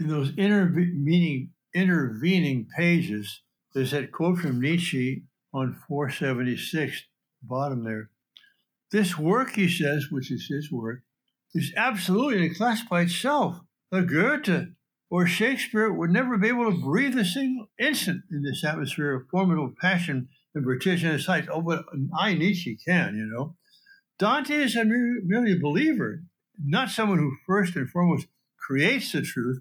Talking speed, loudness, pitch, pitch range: 150 wpm, -25 LUFS, 170 Hz, 140-200 Hz